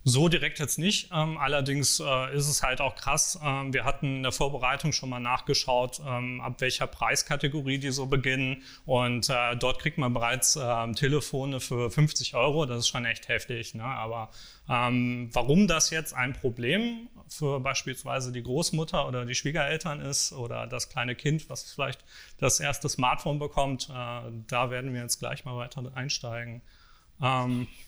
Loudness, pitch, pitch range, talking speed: -28 LUFS, 130 Hz, 125-145 Hz, 155 wpm